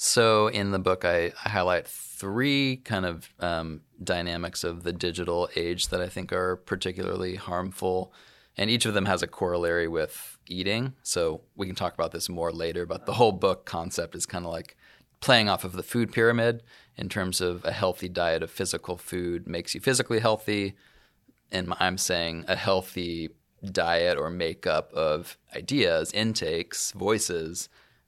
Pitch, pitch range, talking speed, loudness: 90 Hz, 85-105 Hz, 170 wpm, -27 LUFS